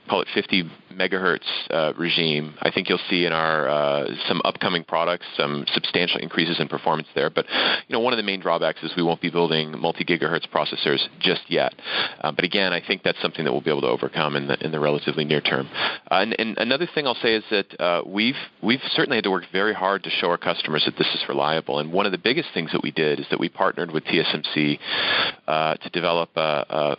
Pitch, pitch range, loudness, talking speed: 80 Hz, 75-85 Hz, -22 LUFS, 235 wpm